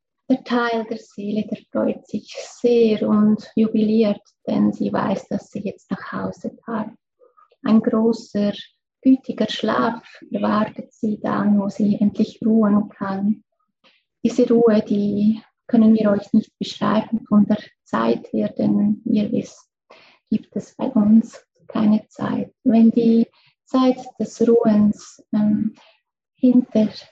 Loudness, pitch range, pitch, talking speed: -20 LUFS, 215-240 Hz, 225 Hz, 130 wpm